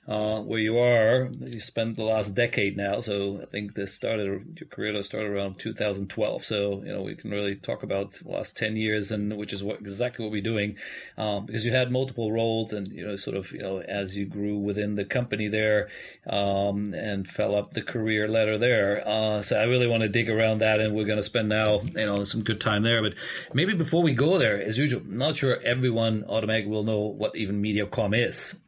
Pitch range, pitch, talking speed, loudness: 100-115 Hz, 105 Hz, 225 wpm, -26 LUFS